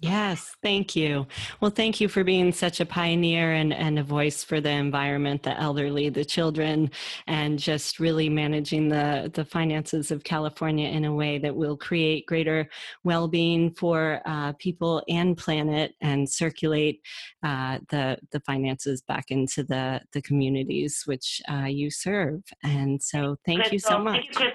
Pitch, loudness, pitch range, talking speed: 155 Hz, -26 LUFS, 145-170 Hz, 160 wpm